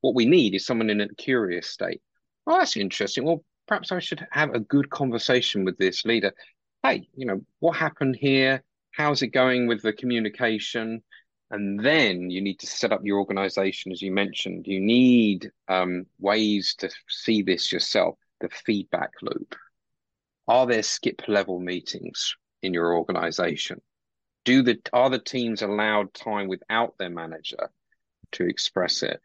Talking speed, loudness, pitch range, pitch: 160 wpm, -24 LUFS, 95-130 Hz, 110 Hz